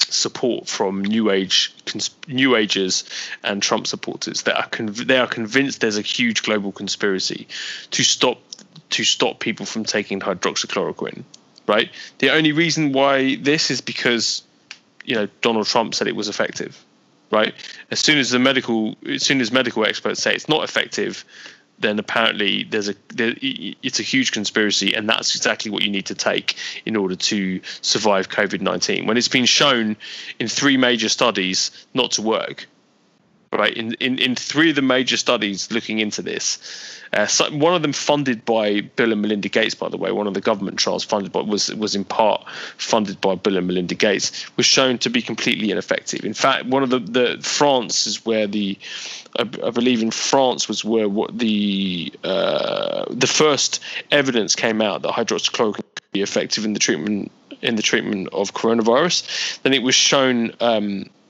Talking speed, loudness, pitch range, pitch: 180 wpm, -19 LUFS, 105-130 Hz, 115 Hz